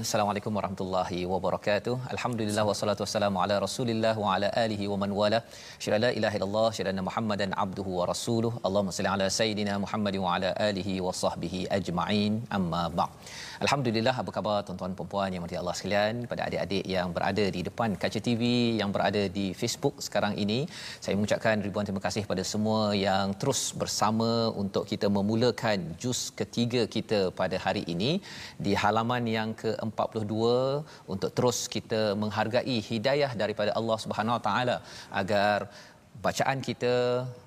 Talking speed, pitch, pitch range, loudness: 150 wpm, 105 Hz, 100-115 Hz, -29 LUFS